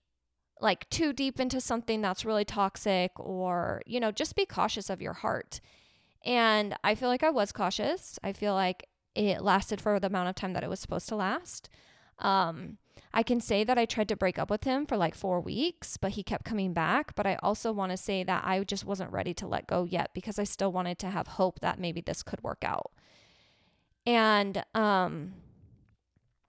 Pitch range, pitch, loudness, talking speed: 185-220 Hz, 195 Hz, -31 LUFS, 205 wpm